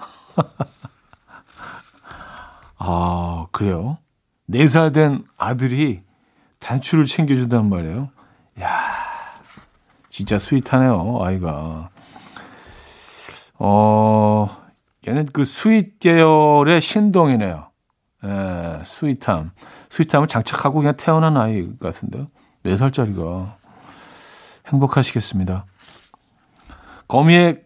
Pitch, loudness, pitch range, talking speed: 125 Hz, -18 LUFS, 95-150 Hz, 185 characters per minute